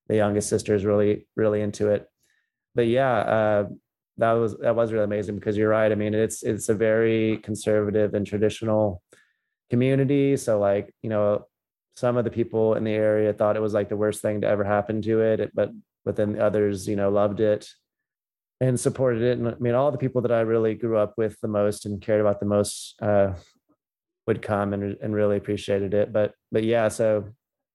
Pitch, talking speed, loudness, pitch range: 105 Hz, 205 wpm, -24 LUFS, 105-115 Hz